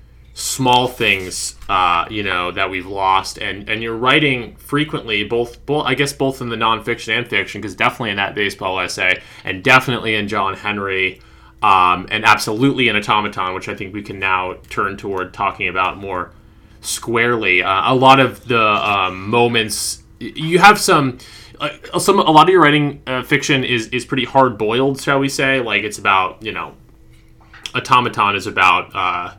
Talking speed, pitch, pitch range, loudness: 180 wpm, 115 Hz, 100-130 Hz, -16 LUFS